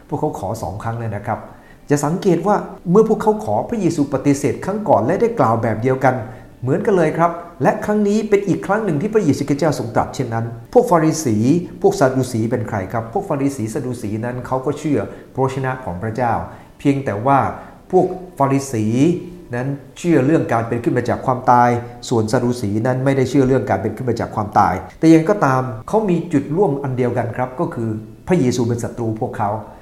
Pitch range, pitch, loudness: 115-160 Hz, 130 Hz, -18 LUFS